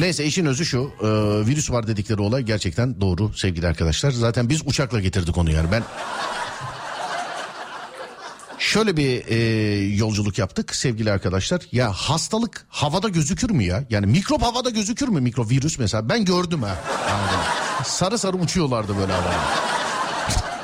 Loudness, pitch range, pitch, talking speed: -22 LUFS, 105-165 Hz, 125 Hz, 145 wpm